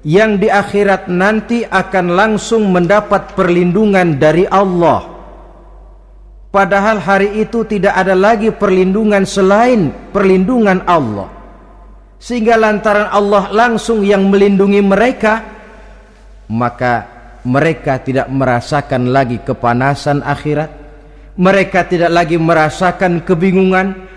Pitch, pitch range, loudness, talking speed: 190 Hz, 155-210 Hz, -12 LUFS, 95 wpm